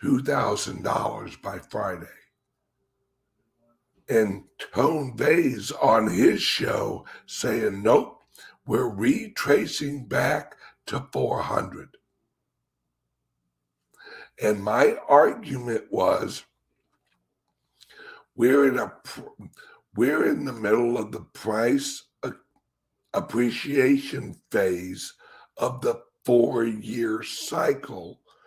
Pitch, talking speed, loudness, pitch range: 120 Hz, 80 wpm, -24 LUFS, 100-145 Hz